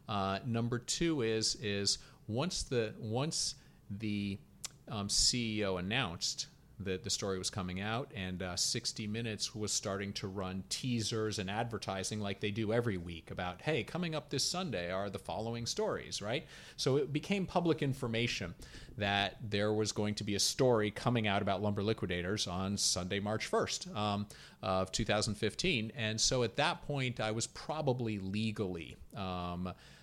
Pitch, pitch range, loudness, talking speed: 110 Hz, 100-120 Hz, -35 LUFS, 160 wpm